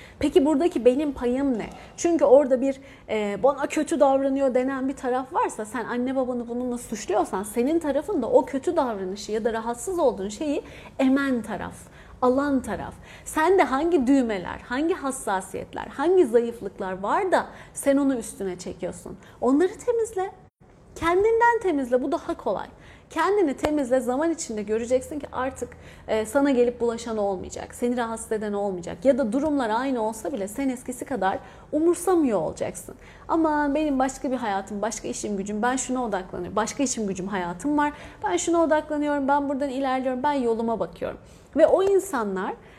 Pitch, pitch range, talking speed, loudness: 265 Hz, 225-300 Hz, 155 wpm, -24 LUFS